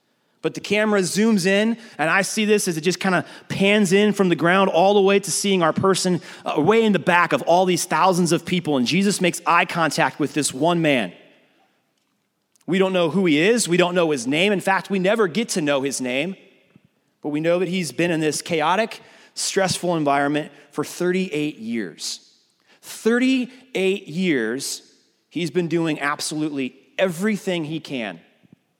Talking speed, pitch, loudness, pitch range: 185 wpm, 180 Hz, -20 LUFS, 155-195 Hz